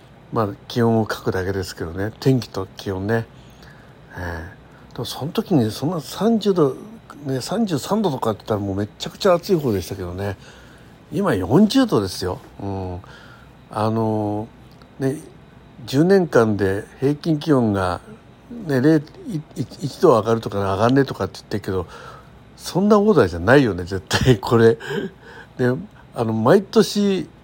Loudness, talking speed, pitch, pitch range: -20 LUFS, 260 characters per minute, 125 Hz, 100-155 Hz